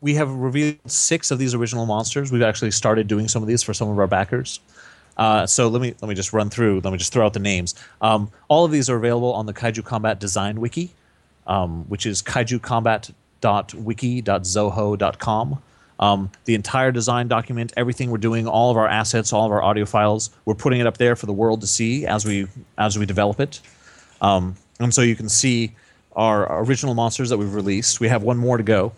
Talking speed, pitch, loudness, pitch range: 215 wpm, 110 Hz, -20 LUFS, 105-120 Hz